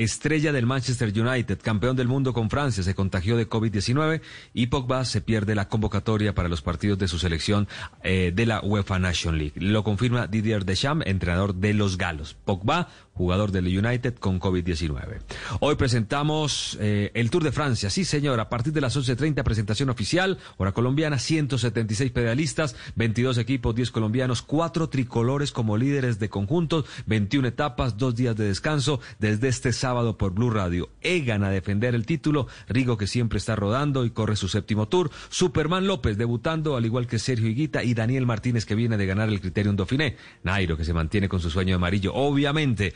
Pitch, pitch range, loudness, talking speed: 115 Hz, 100-135 Hz, -25 LUFS, 180 wpm